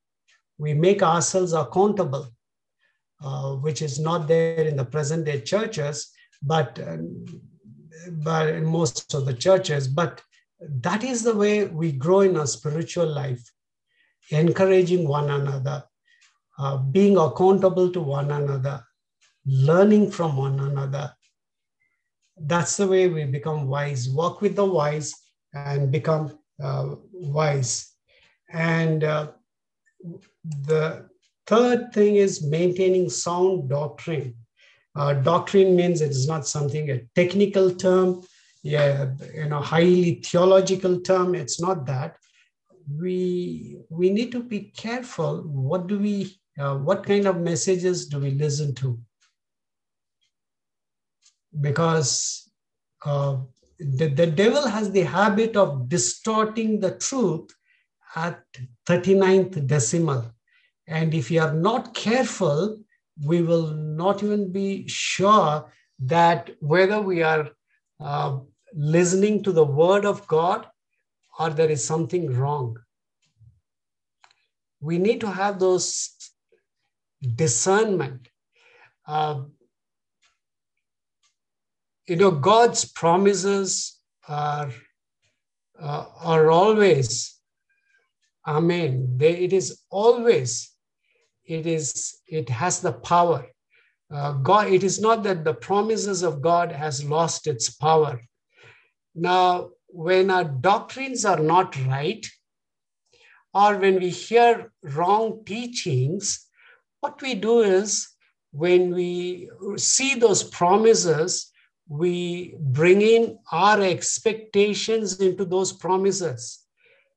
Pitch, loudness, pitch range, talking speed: 170 Hz, -22 LUFS, 150-195 Hz, 110 wpm